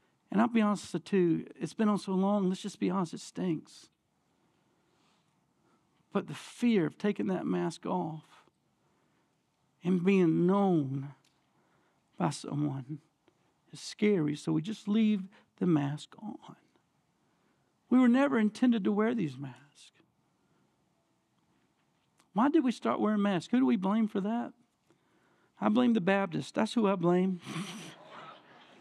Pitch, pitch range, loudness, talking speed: 195 Hz, 165-220 Hz, -30 LUFS, 140 wpm